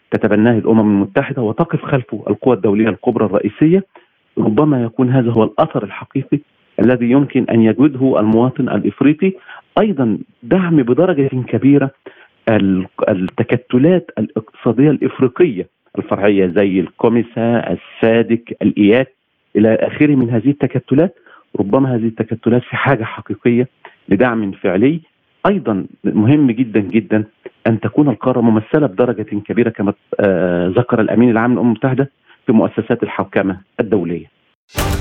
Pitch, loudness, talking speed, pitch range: 115 Hz, -15 LUFS, 115 wpm, 110-135 Hz